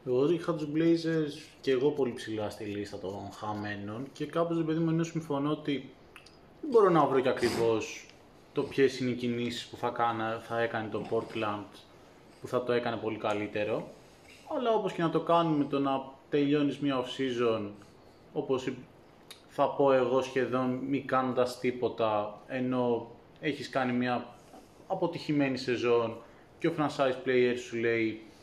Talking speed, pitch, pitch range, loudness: 160 wpm, 125 Hz, 115-140 Hz, -31 LUFS